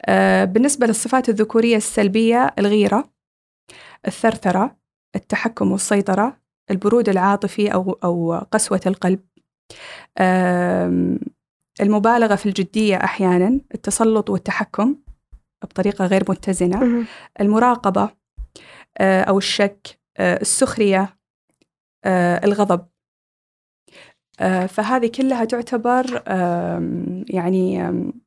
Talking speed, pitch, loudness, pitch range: 70 wpm, 200 Hz, -18 LUFS, 185-225 Hz